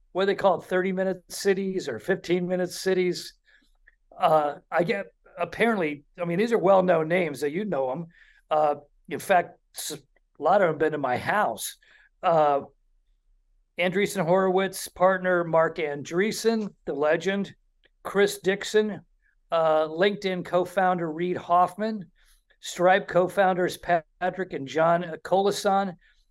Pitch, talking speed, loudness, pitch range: 180 Hz, 140 wpm, -25 LUFS, 160-195 Hz